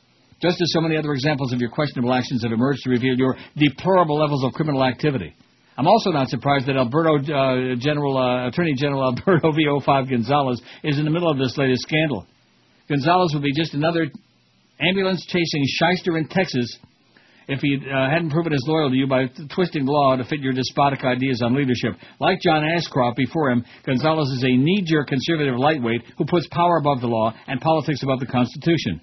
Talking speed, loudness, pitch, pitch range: 195 wpm, -21 LUFS, 140 Hz, 130-160 Hz